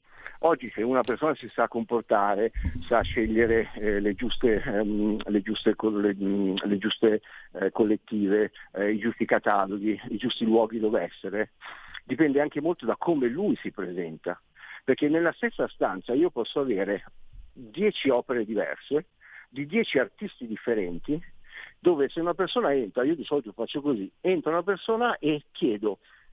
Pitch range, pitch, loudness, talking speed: 105-160 Hz, 115 Hz, -27 LUFS, 155 wpm